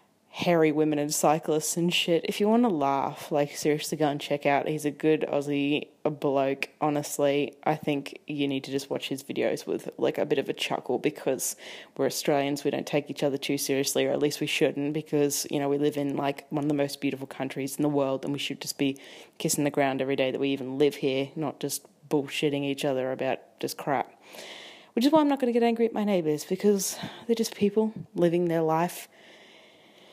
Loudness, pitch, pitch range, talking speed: -27 LUFS, 145 Hz, 140-160 Hz, 225 wpm